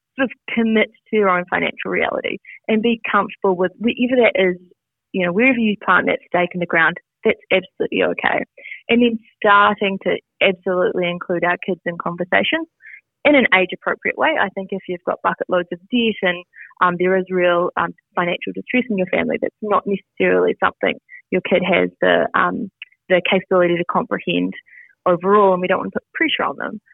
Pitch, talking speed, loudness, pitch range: 190 Hz, 190 wpm, -18 LUFS, 180-220 Hz